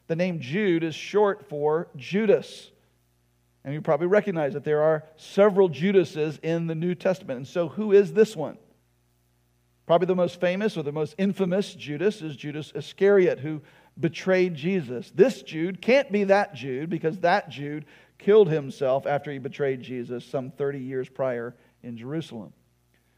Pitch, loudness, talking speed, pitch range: 155 Hz, -25 LUFS, 160 wpm, 135-190 Hz